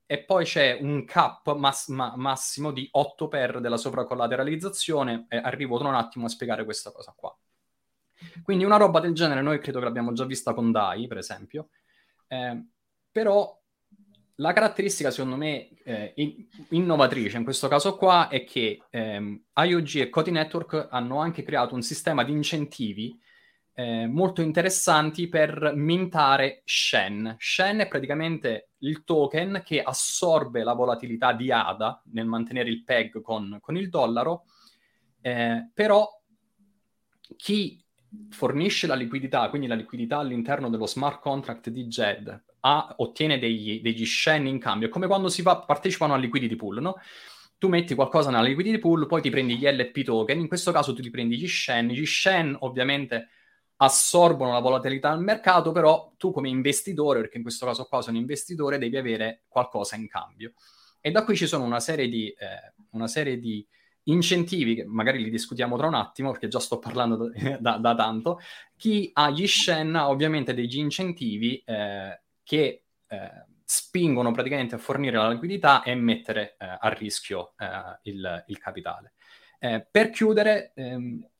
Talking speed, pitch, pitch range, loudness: 160 wpm, 140 Hz, 120-165 Hz, -25 LUFS